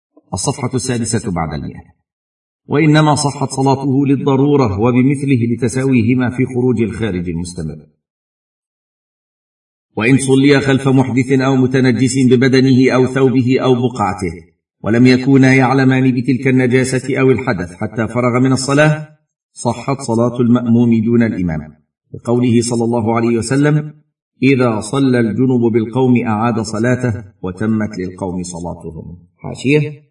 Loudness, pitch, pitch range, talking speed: -14 LUFS, 125 Hz, 110-135 Hz, 110 wpm